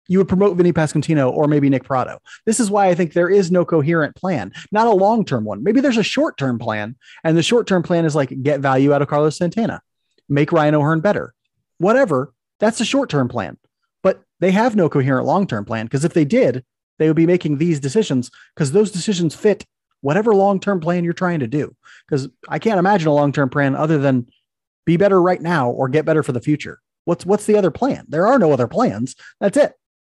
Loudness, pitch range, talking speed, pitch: -17 LUFS, 140-195 Hz, 220 wpm, 160 Hz